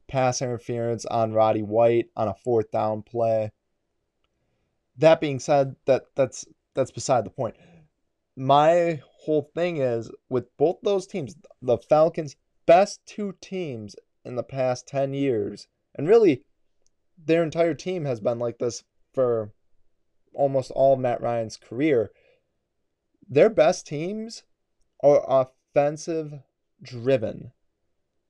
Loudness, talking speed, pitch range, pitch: -24 LUFS, 125 wpm, 115-160 Hz, 135 Hz